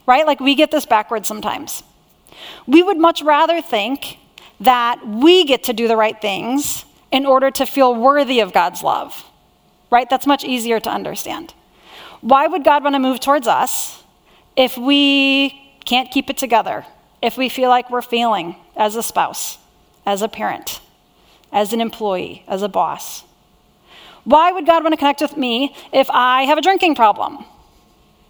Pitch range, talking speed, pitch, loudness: 230-285 Hz, 170 wpm, 260 Hz, -16 LUFS